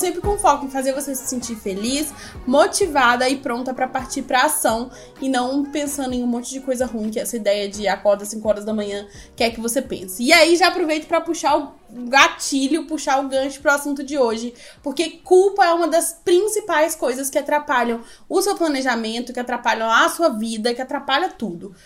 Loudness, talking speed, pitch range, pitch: -19 LUFS, 205 wpm, 240-310 Hz, 270 Hz